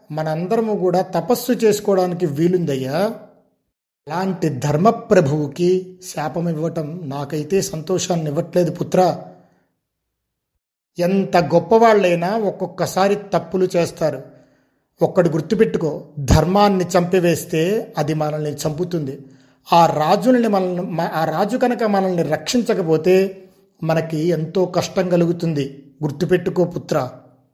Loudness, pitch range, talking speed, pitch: -19 LUFS, 155-190 Hz, 85 wpm, 175 Hz